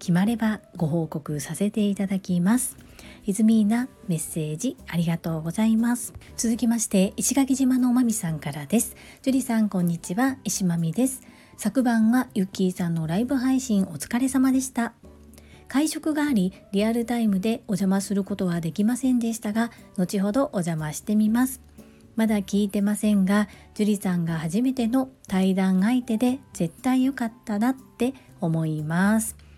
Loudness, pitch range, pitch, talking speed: -24 LUFS, 185-240 Hz, 210 Hz, 340 characters per minute